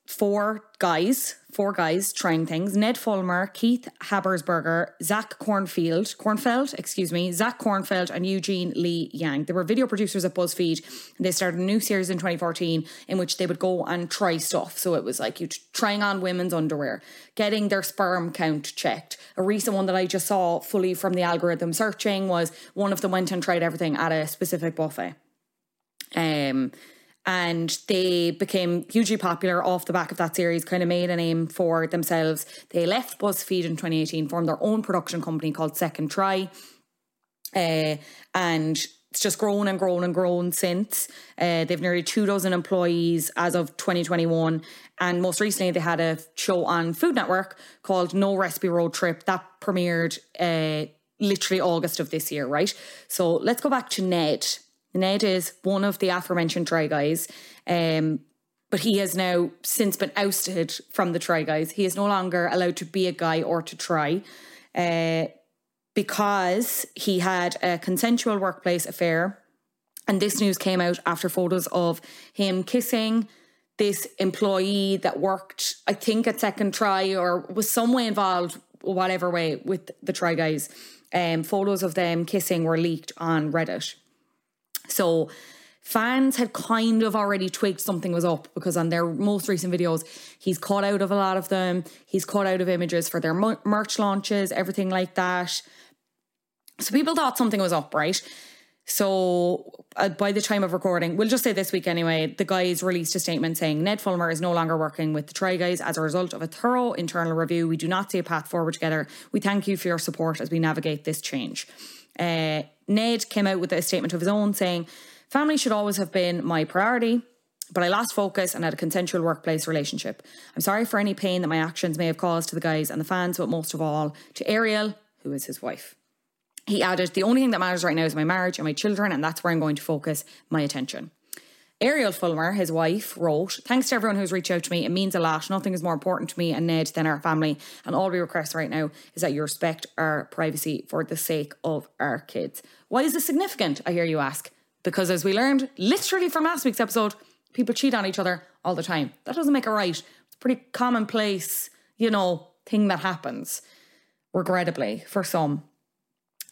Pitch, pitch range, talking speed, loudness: 180 Hz, 165-200 Hz, 195 wpm, -25 LUFS